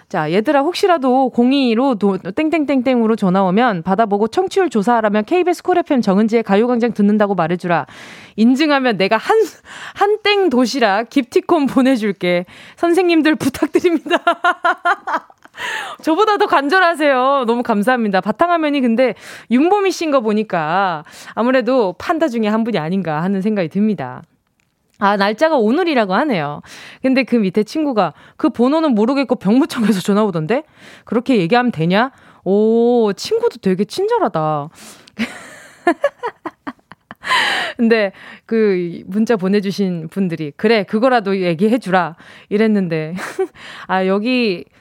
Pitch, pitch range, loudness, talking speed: 235 Hz, 200-305 Hz, -16 LUFS, 300 characters per minute